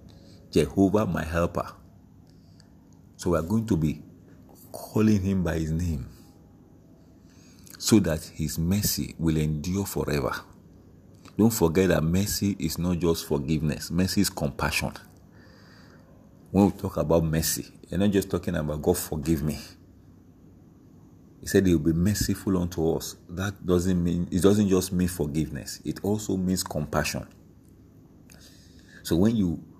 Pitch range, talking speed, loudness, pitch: 80-95 Hz, 135 wpm, -26 LUFS, 90 Hz